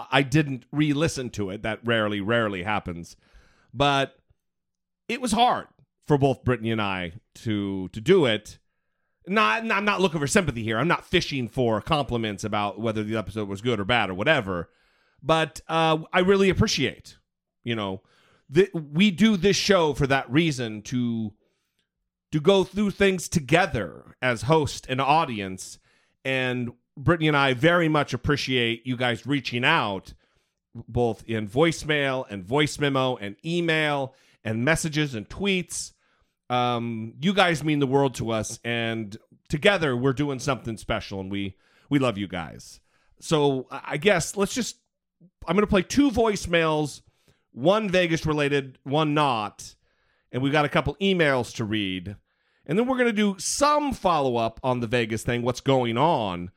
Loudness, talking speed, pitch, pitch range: -24 LUFS, 160 wpm, 135 Hz, 115-165 Hz